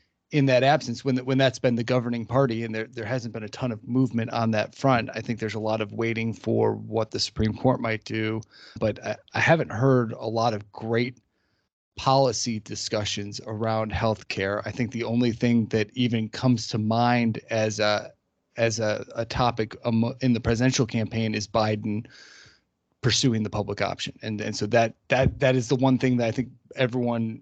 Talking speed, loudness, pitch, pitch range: 200 wpm, -25 LUFS, 115 Hz, 110-125 Hz